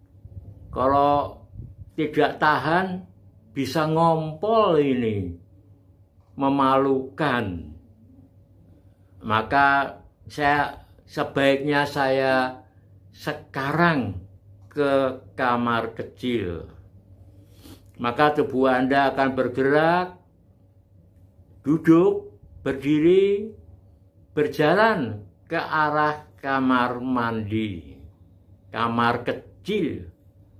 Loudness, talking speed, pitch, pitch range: -23 LUFS, 55 wpm, 120 Hz, 95-145 Hz